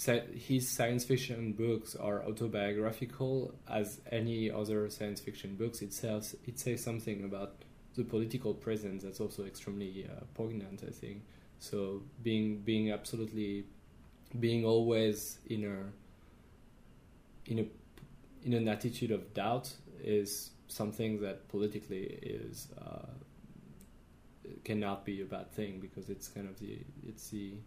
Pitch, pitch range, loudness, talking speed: 105 Hz, 100-115 Hz, -38 LUFS, 130 wpm